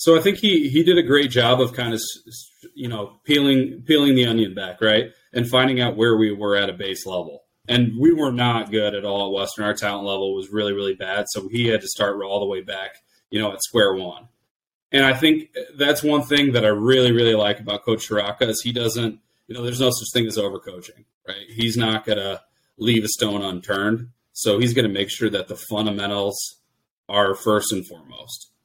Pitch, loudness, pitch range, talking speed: 115 Hz, -20 LUFS, 105-125 Hz, 225 wpm